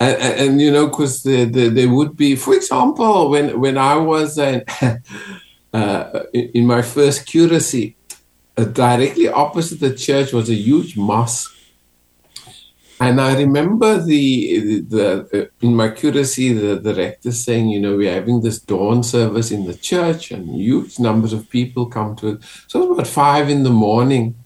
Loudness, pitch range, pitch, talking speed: -16 LUFS, 110-145 Hz, 125 Hz, 180 wpm